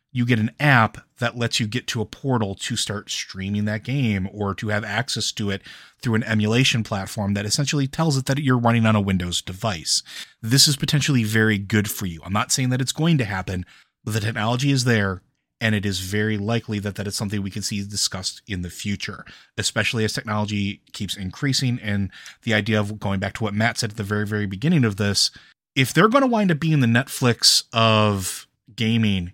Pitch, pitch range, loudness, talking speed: 110 Hz, 100-125 Hz, -22 LUFS, 215 wpm